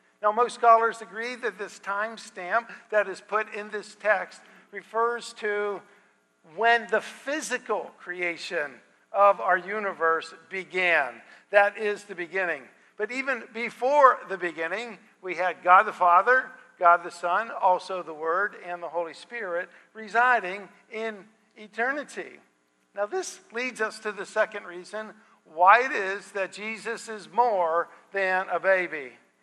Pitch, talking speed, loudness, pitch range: 205 Hz, 140 wpm, -26 LUFS, 180-225 Hz